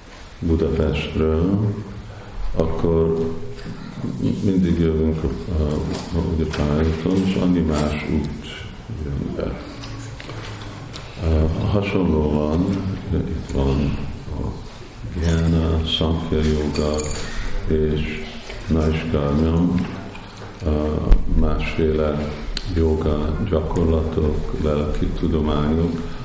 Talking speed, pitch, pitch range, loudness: 60 wpm, 80 Hz, 75-95 Hz, -22 LUFS